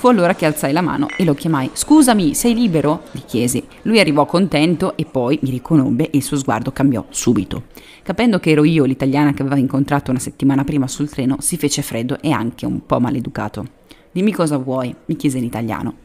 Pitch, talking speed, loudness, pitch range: 145 Hz, 205 wpm, -17 LUFS, 135-165 Hz